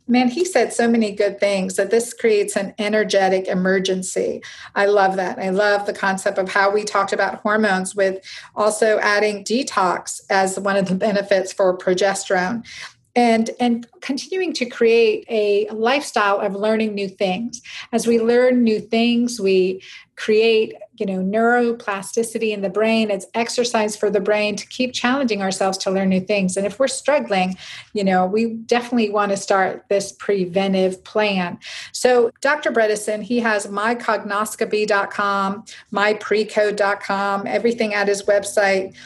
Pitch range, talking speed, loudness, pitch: 195-230 Hz, 150 wpm, -19 LUFS, 210 Hz